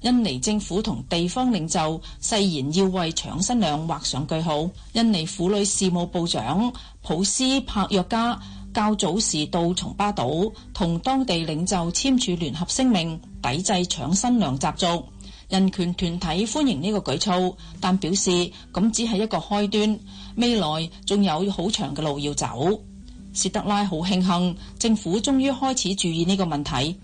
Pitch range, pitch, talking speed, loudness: 170-210 Hz, 190 Hz, 235 characters per minute, -23 LUFS